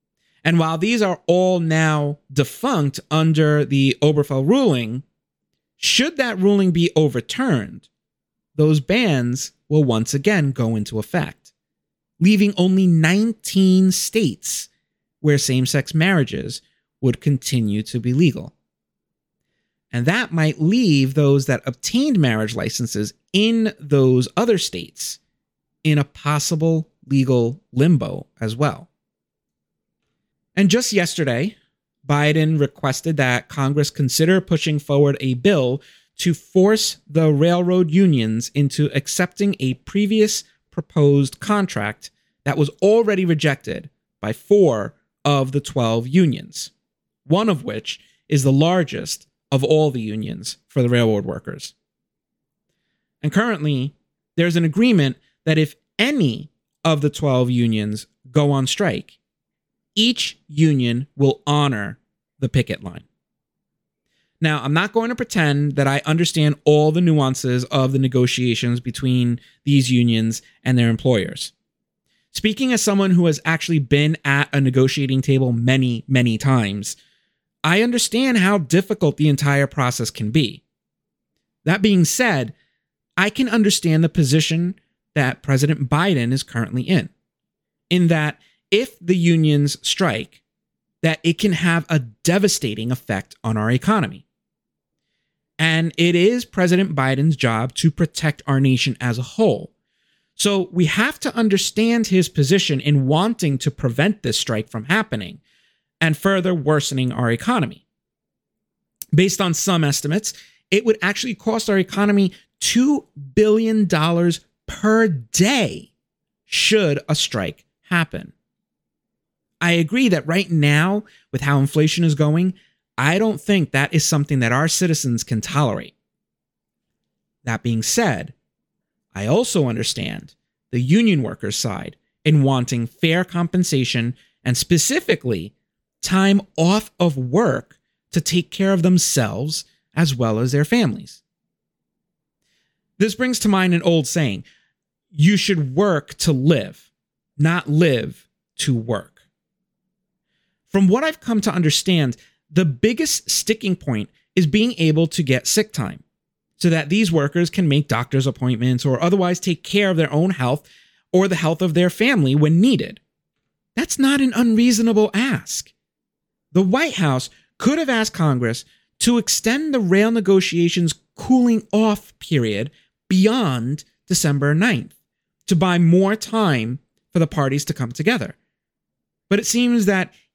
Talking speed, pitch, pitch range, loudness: 130 wpm, 155 Hz, 135-190 Hz, -19 LUFS